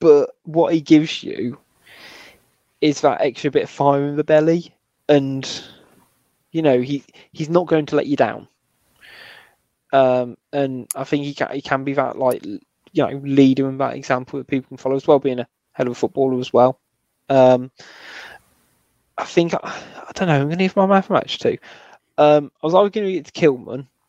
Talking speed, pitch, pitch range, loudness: 195 wpm, 140 Hz, 135-155 Hz, -19 LUFS